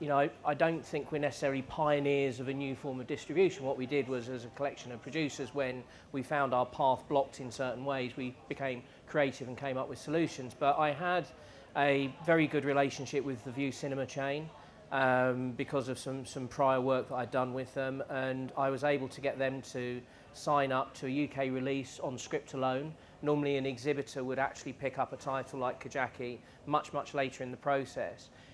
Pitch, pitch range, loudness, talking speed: 135 Hz, 130-145 Hz, -34 LUFS, 205 wpm